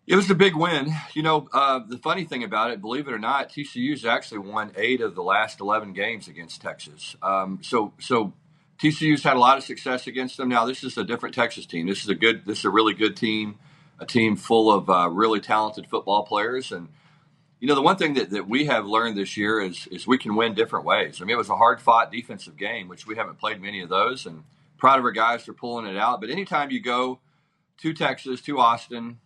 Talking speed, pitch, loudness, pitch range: 240 wpm, 125 Hz, -23 LUFS, 115-155 Hz